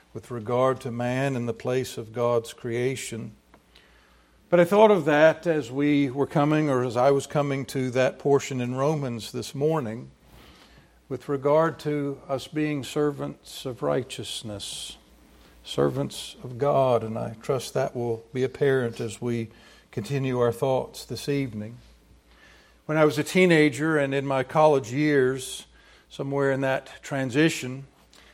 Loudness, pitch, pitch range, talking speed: -25 LUFS, 135 Hz, 120-145 Hz, 150 wpm